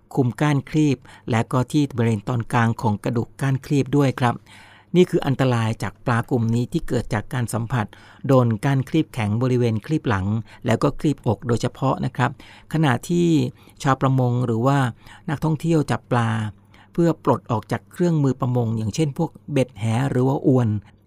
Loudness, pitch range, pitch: -22 LUFS, 115-140 Hz, 125 Hz